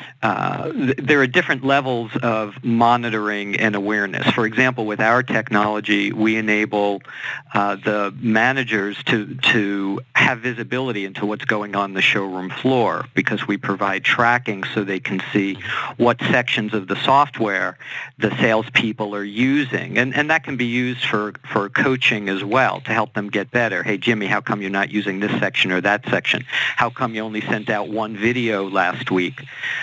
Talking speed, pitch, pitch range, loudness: 175 wpm, 110 Hz, 100-120 Hz, -19 LUFS